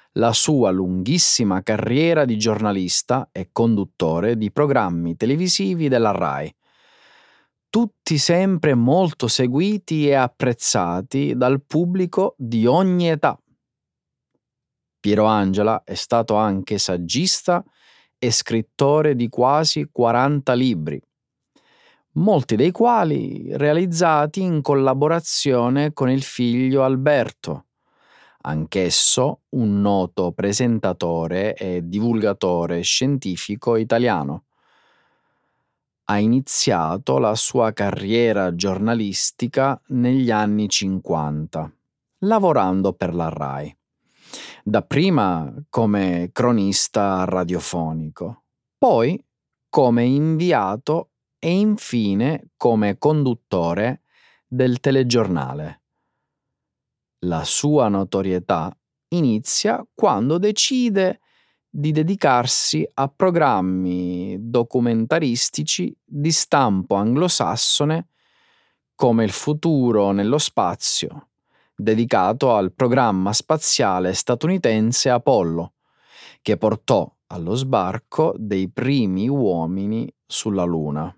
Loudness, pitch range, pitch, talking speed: -19 LUFS, 100-150 Hz, 120 Hz, 85 wpm